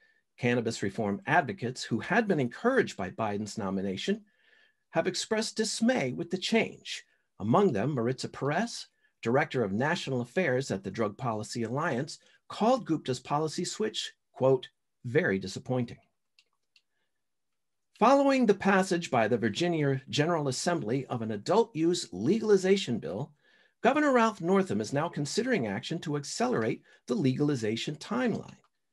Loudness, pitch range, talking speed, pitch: -29 LUFS, 125-210 Hz, 130 wpm, 160 Hz